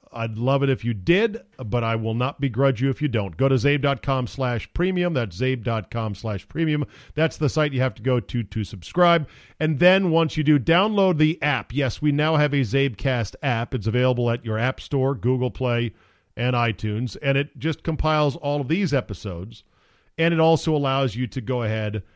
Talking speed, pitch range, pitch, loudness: 205 wpm, 115-150 Hz, 135 Hz, -23 LUFS